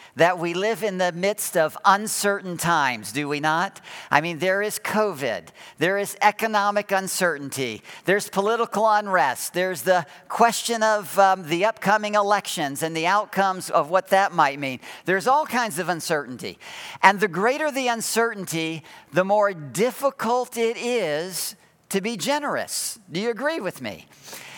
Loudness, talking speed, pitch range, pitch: -23 LUFS, 155 wpm, 170-220 Hz, 195 Hz